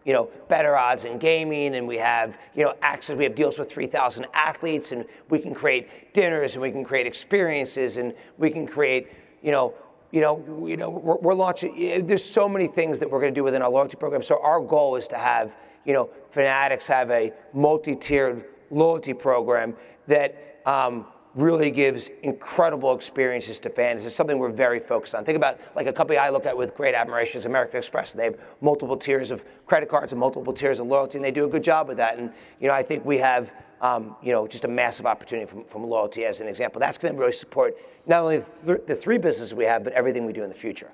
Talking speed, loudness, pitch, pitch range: 230 wpm, -24 LUFS, 140 Hz, 125-155 Hz